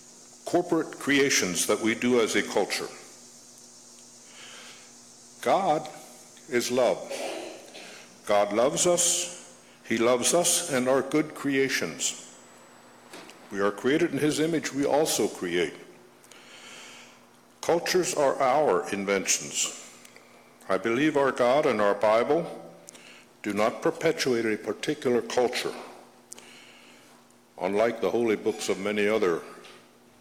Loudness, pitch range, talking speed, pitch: -26 LUFS, 110-155 Hz, 105 wpm, 130 Hz